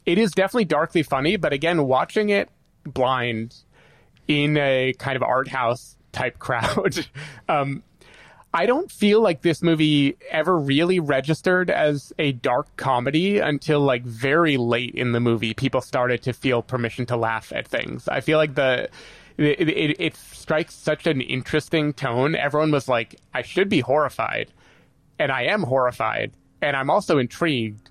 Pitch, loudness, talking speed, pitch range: 140 Hz, -22 LUFS, 160 wpm, 125-155 Hz